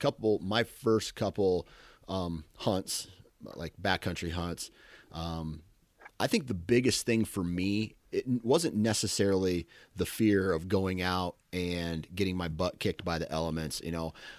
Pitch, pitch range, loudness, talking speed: 90 Hz, 85-105 Hz, -32 LUFS, 145 wpm